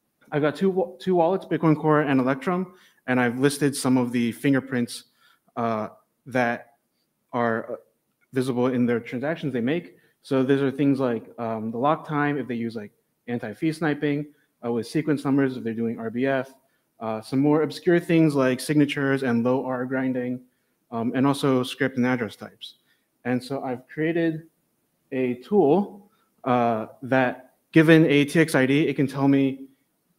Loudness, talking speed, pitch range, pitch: -24 LUFS, 165 wpm, 125-150 Hz, 135 Hz